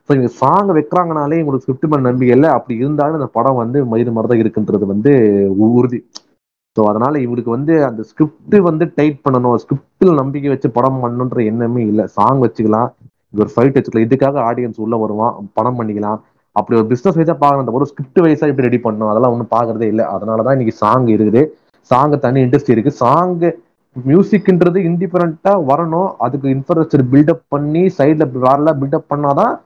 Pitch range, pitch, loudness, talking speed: 115-150 Hz, 135 Hz, -14 LUFS, 160 wpm